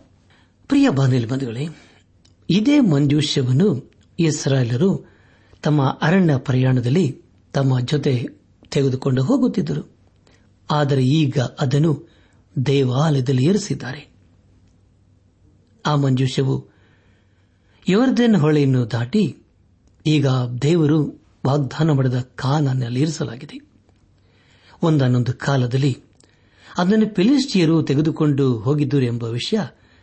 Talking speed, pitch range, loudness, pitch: 75 wpm, 115-155 Hz, -19 LUFS, 135 Hz